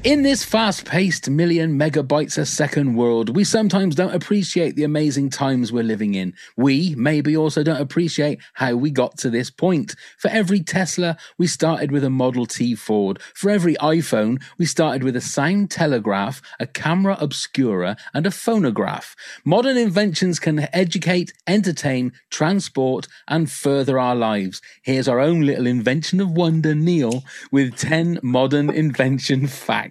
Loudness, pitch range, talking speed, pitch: -20 LUFS, 130-175 Hz, 155 wpm, 150 Hz